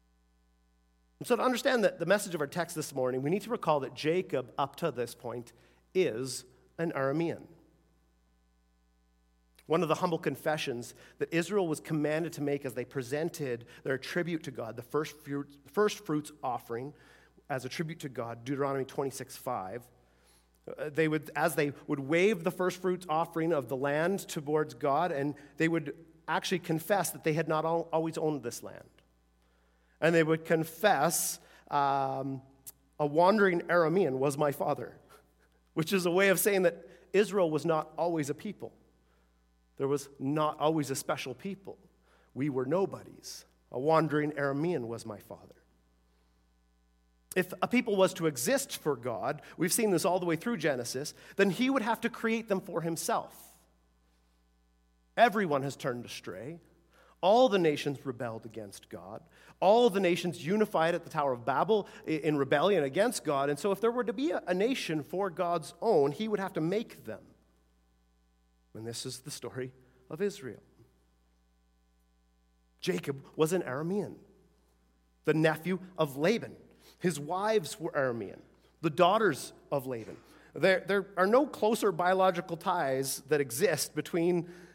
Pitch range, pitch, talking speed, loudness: 120-175 Hz, 150 Hz, 155 wpm, -31 LUFS